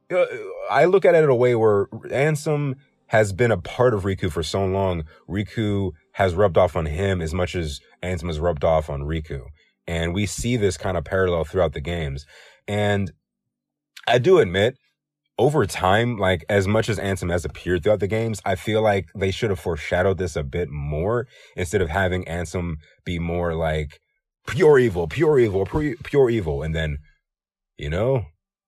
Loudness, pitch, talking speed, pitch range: -22 LUFS, 95 Hz, 185 wpm, 85-110 Hz